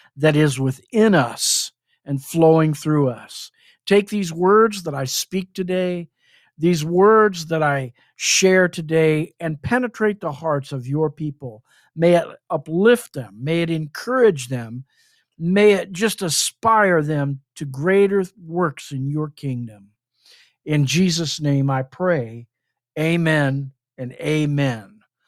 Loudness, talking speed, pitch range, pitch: -19 LUFS, 130 wpm, 140-185 Hz, 155 Hz